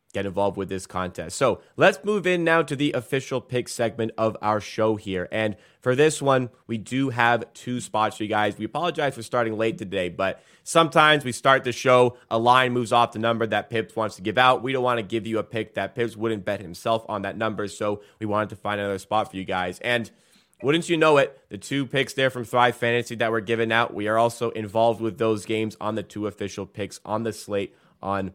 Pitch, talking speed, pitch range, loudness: 115 Hz, 240 wpm, 105-125 Hz, -24 LUFS